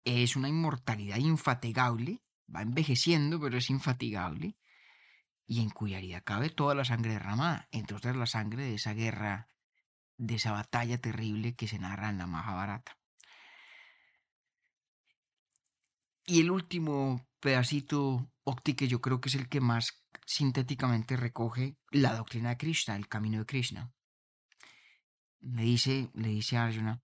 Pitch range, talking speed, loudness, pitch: 110-140 Hz, 140 wpm, -33 LUFS, 120 Hz